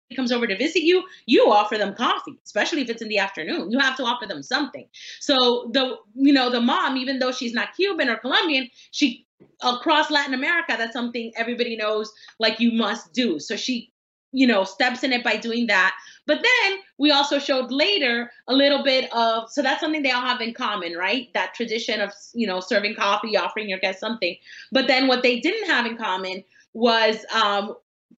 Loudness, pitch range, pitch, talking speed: -21 LUFS, 220-275 Hz, 245 Hz, 205 wpm